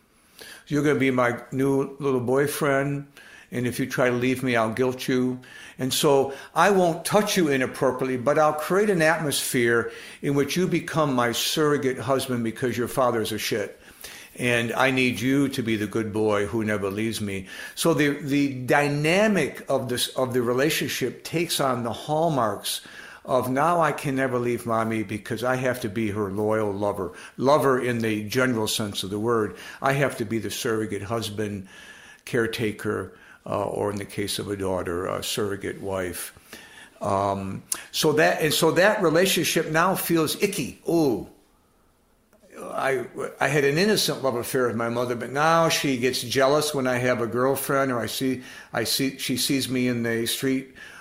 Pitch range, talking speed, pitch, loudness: 115-145 Hz, 185 wpm, 130 Hz, -24 LUFS